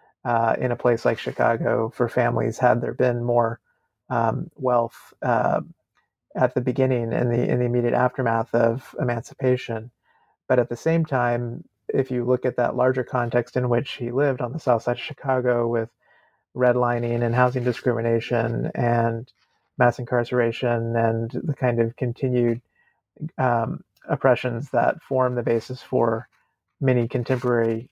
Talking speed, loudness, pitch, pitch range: 150 wpm, -23 LUFS, 120 Hz, 120-125 Hz